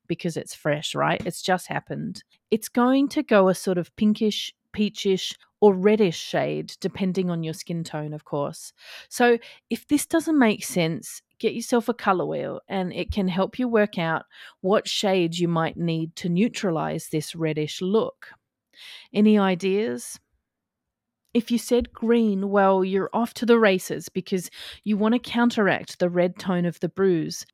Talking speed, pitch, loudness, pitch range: 170 wpm, 195 Hz, -24 LUFS, 175-225 Hz